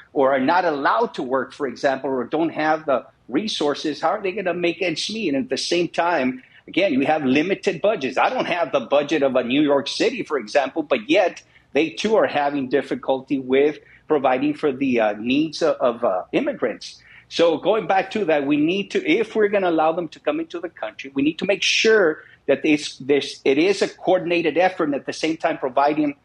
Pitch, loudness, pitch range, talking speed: 160 Hz, -21 LUFS, 140-195 Hz, 225 wpm